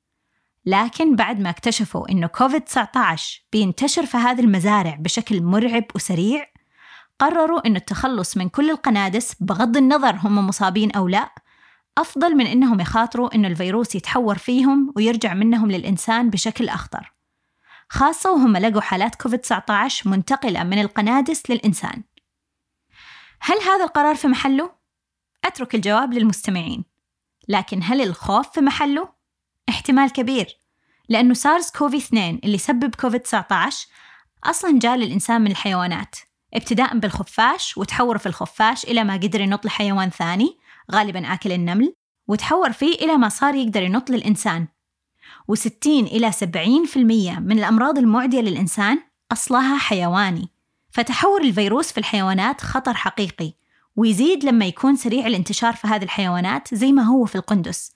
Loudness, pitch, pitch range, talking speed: -19 LUFS, 225 Hz, 200-265 Hz, 130 wpm